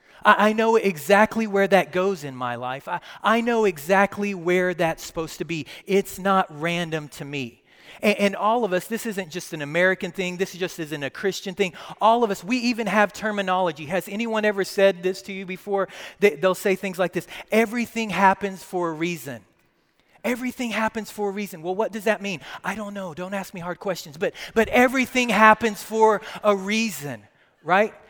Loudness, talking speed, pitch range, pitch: -23 LUFS, 195 wpm, 180-215 Hz, 195 Hz